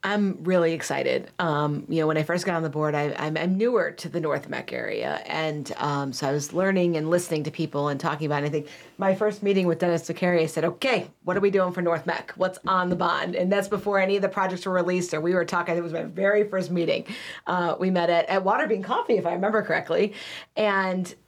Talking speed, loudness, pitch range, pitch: 245 wpm, -25 LUFS, 165-195 Hz, 175 Hz